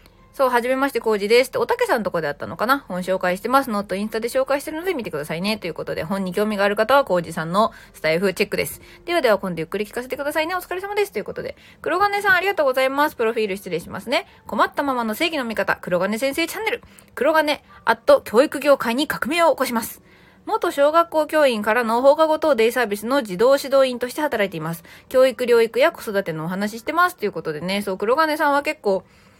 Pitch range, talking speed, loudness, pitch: 205-310 Hz, 500 characters per minute, -20 LUFS, 255 Hz